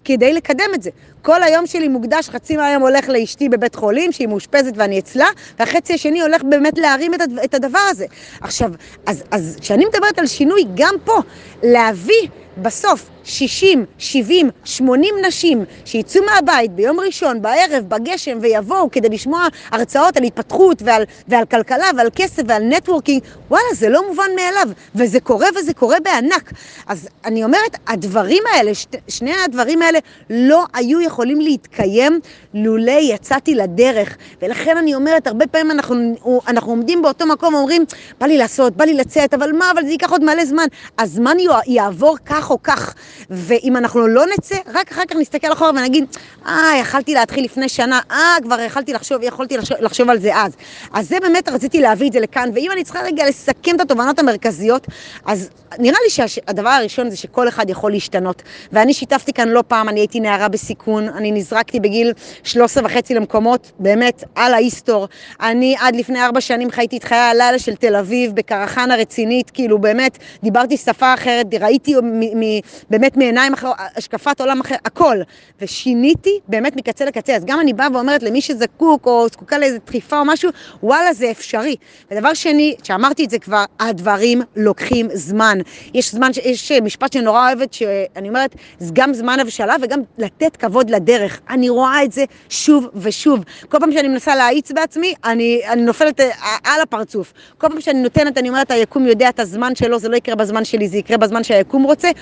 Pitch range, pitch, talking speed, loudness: 230-300 Hz, 255 Hz, 175 wpm, -15 LUFS